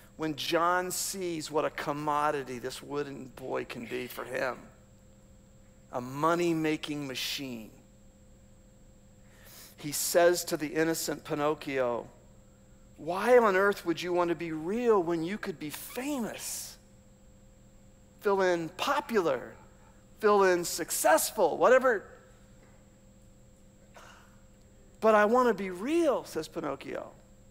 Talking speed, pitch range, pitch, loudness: 115 wpm, 135-190 Hz, 160 Hz, -29 LUFS